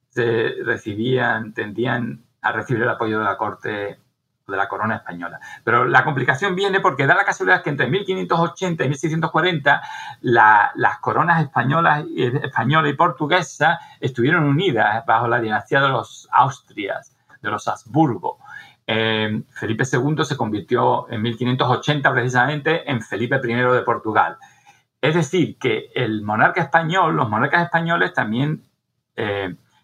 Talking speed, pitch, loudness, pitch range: 135 wpm, 140 Hz, -19 LUFS, 120-165 Hz